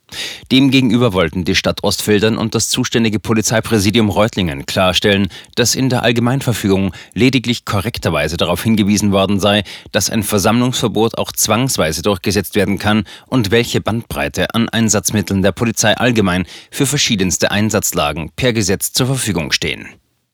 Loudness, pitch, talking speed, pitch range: -15 LUFS, 105 Hz, 135 wpm, 95-115 Hz